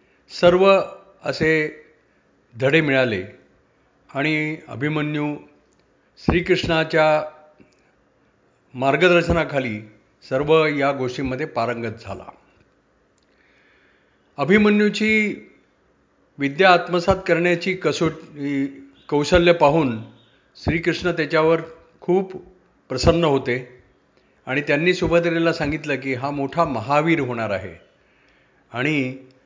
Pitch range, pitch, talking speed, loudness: 130-170 Hz, 150 Hz, 75 wpm, -20 LUFS